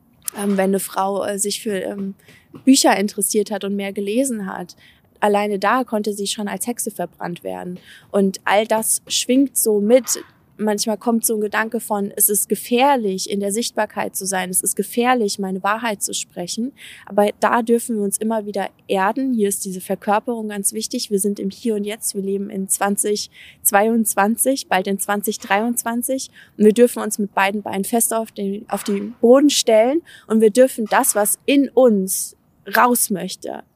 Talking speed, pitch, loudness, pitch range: 180 wpm, 210 Hz, -19 LUFS, 200-230 Hz